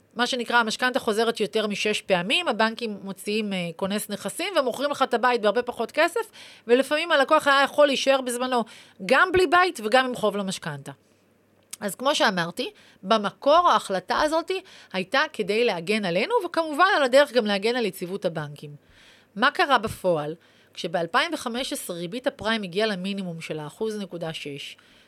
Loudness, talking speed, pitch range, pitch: -24 LUFS, 145 wpm, 195-270 Hz, 230 Hz